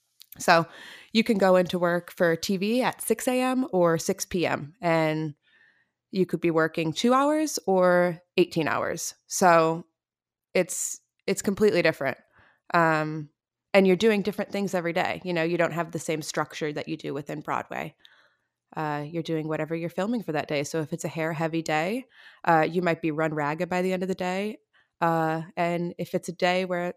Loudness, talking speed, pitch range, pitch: -26 LUFS, 190 wpm, 160-185 Hz, 170 Hz